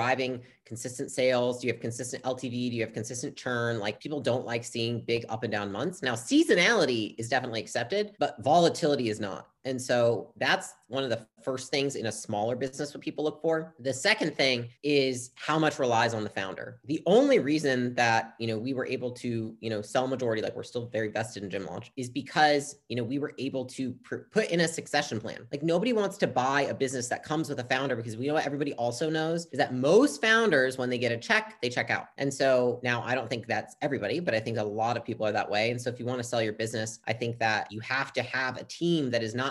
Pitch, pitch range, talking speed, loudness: 130 Hz, 115-145 Hz, 250 wpm, -29 LUFS